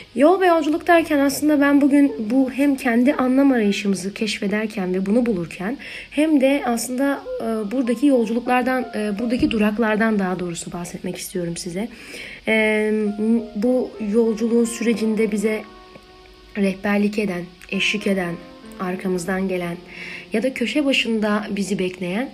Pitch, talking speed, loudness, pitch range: 220 Hz, 120 wpm, -20 LUFS, 195-255 Hz